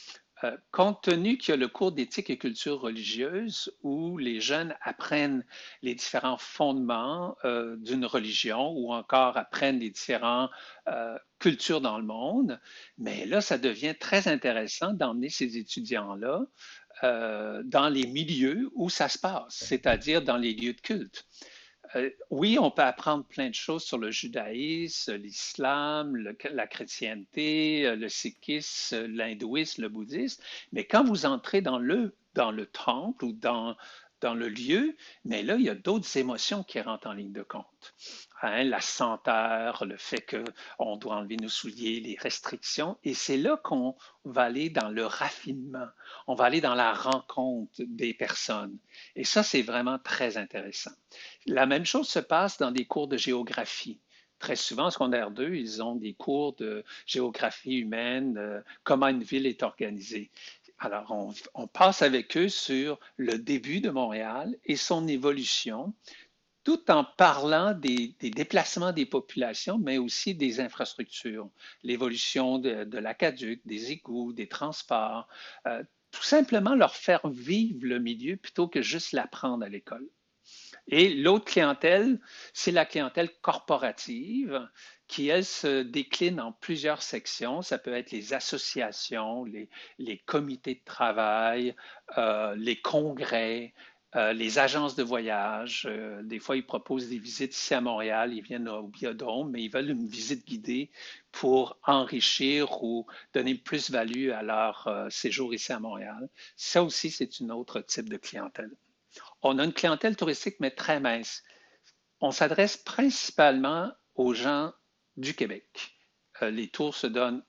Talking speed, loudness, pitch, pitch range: 155 wpm, -29 LUFS, 135 Hz, 120-180 Hz